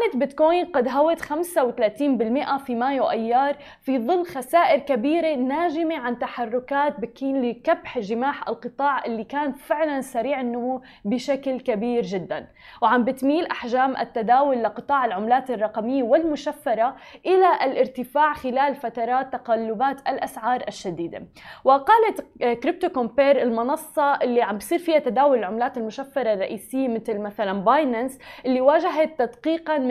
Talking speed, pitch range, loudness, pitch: 120 wpm, 240-295 Hz, -23 LUFS, 265 Hz